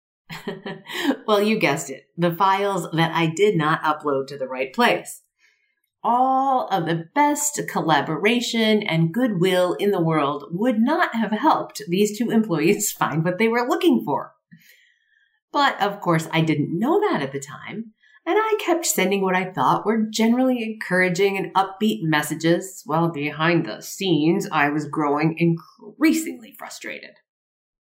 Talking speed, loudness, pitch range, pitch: 155 wpm, -21 LUFS, 160-240 Hz, 195 Hz